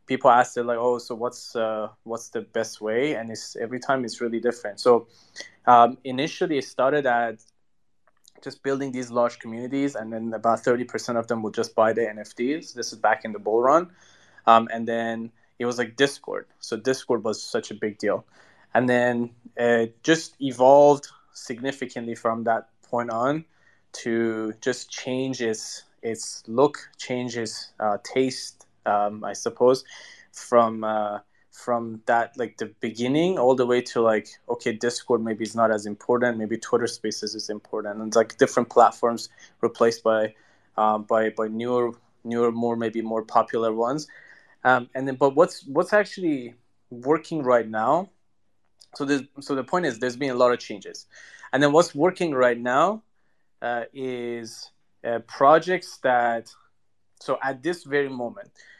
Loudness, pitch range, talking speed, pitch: -24 LUFS, 110-130 Hz, 165 wpm, 120 Hz